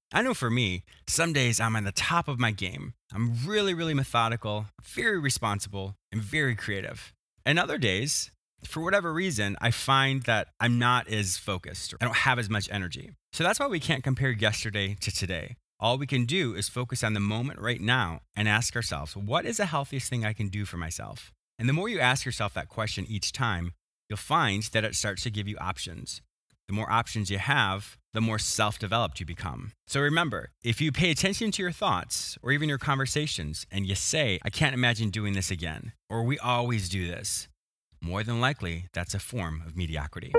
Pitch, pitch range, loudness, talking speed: 110 Hz, 100-130 Hz, -28 LUFS, 210 wpm